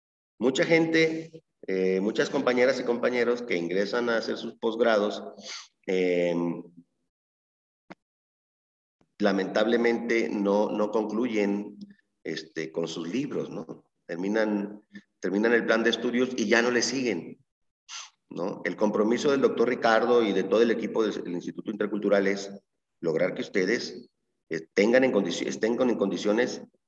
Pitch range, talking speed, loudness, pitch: 100-120 Hz, 135 wpm, -26 LUFS, 110 Hz